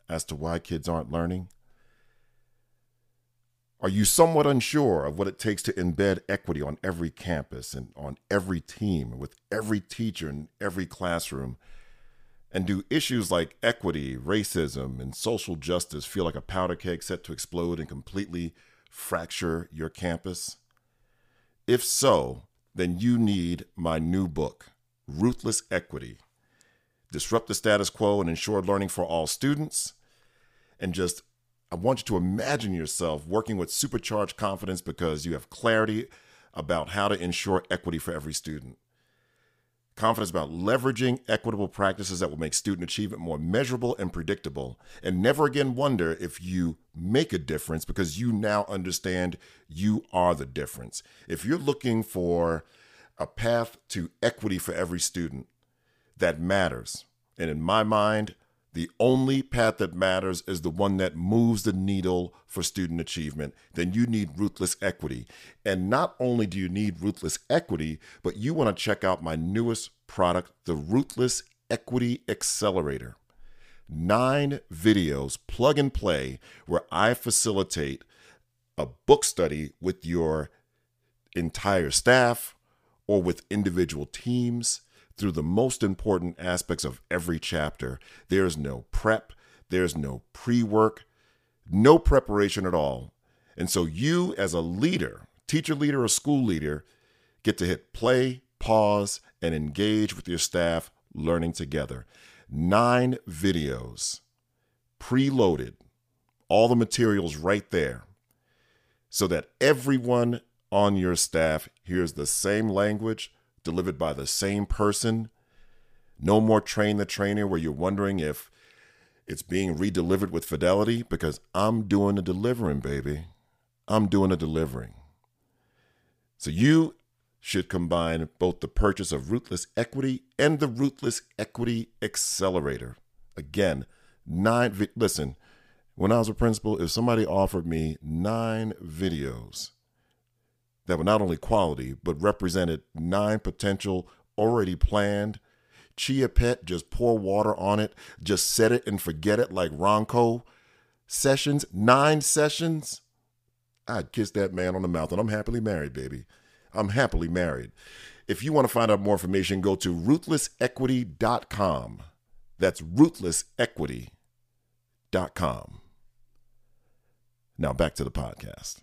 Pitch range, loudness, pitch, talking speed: 85-120 Hz, -27 LUFS, 100 Hz, 135 wpm